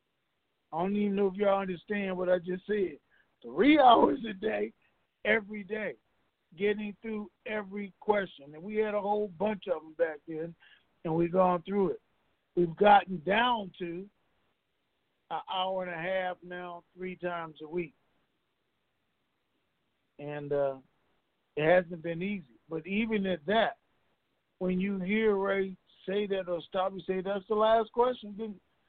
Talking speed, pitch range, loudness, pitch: 155 wpm, 175-210 Hz, -30 LUFS, 190 Hz